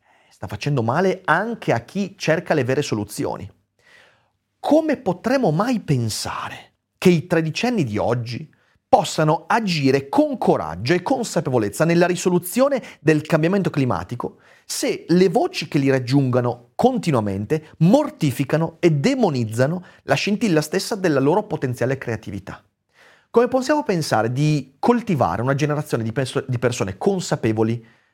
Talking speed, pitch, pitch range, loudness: 125 wpm, 155 Hz, 125-190 Hz, -20 LUFS